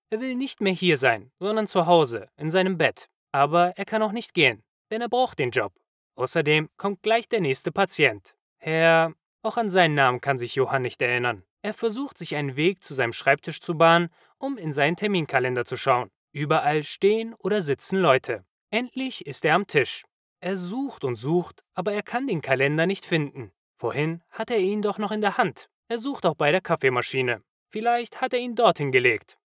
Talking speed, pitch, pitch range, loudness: 200 wpm, 175 Hz, 145-220 Hz, -24 LUFS